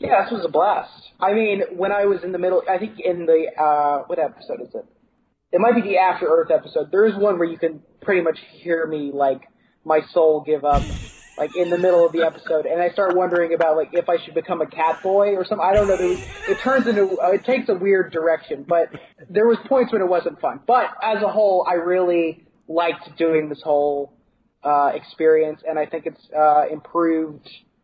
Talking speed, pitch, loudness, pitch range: 220 wpm, 170 Hz, -20 LUFS, 160-200 Hz